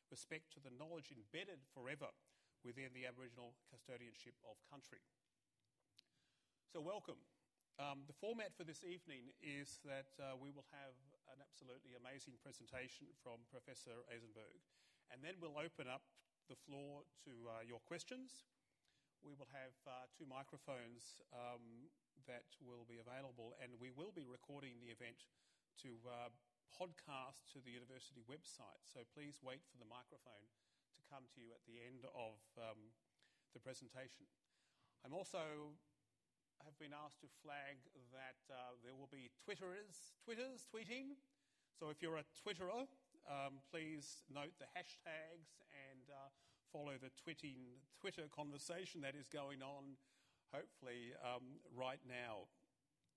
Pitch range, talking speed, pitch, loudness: 125-155 Hz, 140 wpm, 135 Hz, -56 LUFS